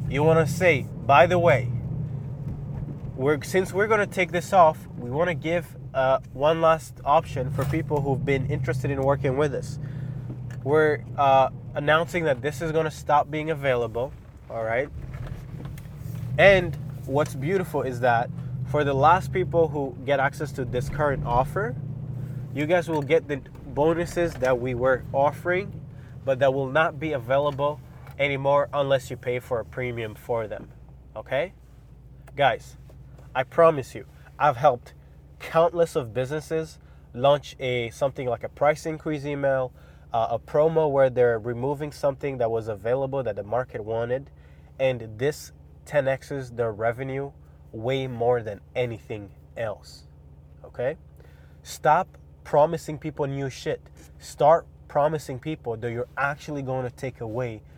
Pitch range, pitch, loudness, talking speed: 125-150 Hz, 135 Hz, -25 LUFS, 145 wpm